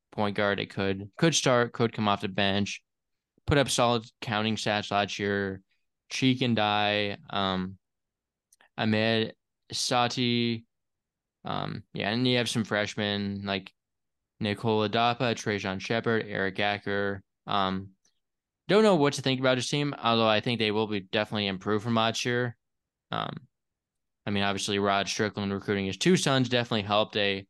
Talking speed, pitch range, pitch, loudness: 155 wpm, 100-120 Hz, 105 Hz, -27 LUFS